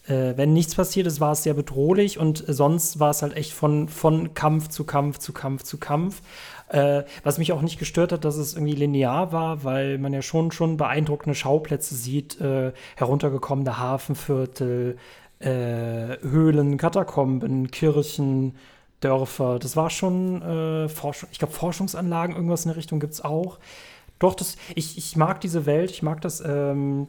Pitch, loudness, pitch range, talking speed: 150 Hz, -24 LUFS, 140-165 Hz, 170 wpm